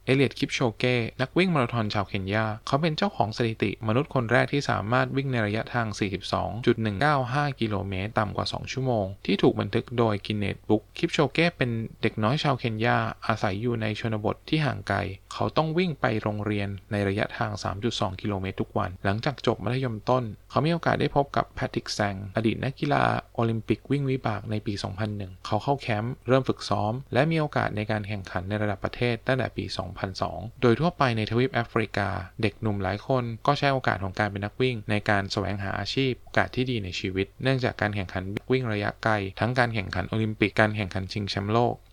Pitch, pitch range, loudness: 110 Hz, 105-130 Hz, -27 LUFS